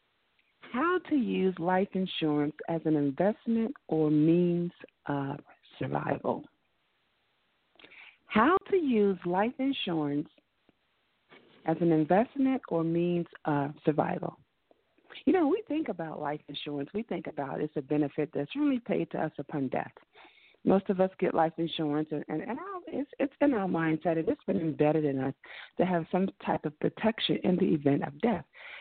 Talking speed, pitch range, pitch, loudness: 155 wpm, 155-220 Hz, 175 Hz, -30 LUFS